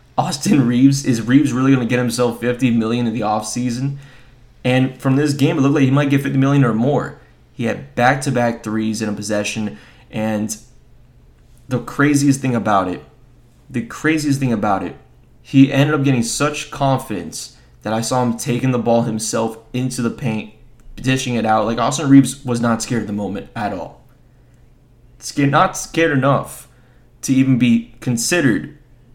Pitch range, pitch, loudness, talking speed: 115-135 Hz, 125 Hz, -17 LUFS, 175 wpm